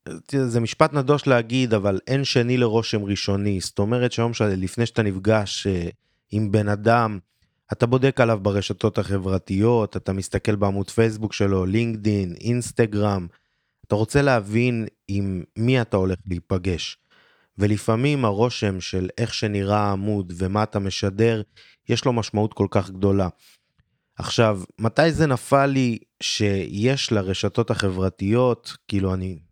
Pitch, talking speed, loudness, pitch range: 105 Hz, 130 wpm, -22 LUFS, 100-120 Hz